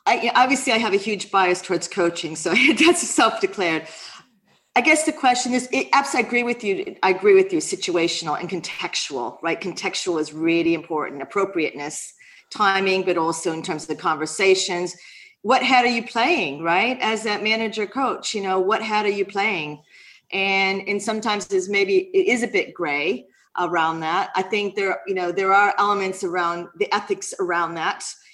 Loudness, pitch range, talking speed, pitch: -21 LUFS, 175-250 Hz, 180 wpm, 200 Hz